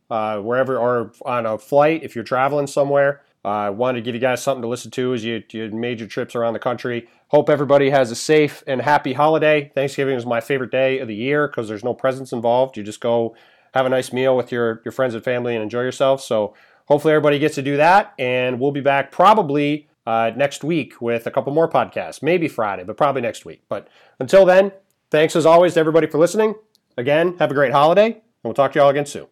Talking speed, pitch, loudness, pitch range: 235 wpm, 130 Hz, -18 LUFS, 120-145 Hz